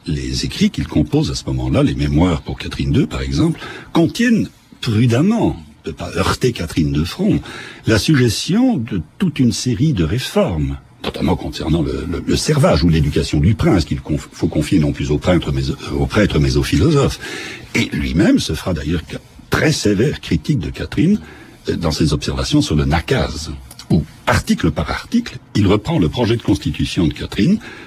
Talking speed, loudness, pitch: 175 wpm, -17 LUFS, 105 Hz